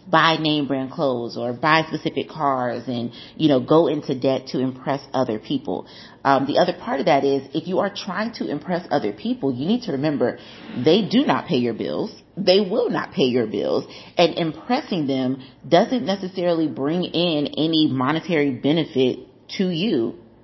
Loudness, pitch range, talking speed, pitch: -21 LUFS, 130-175 Hz, 180 wpm, 150 Hz